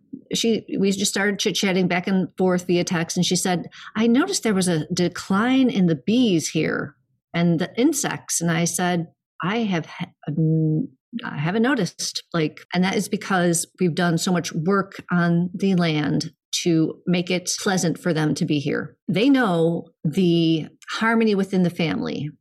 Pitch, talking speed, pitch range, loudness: 180 Hz, 170 wpm, 165-195 Hz, -22 LUFS